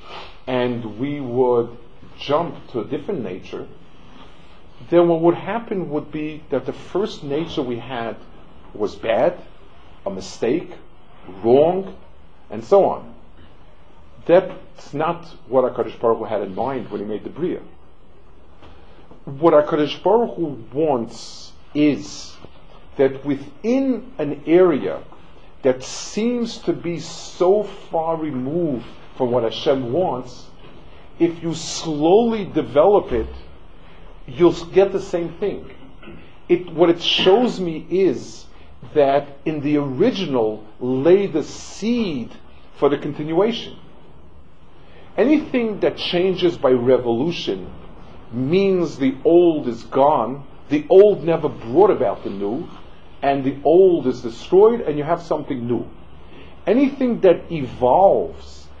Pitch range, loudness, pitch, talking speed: 115-175 Hz, -19 LUFS, 150 Hz, 120 wpm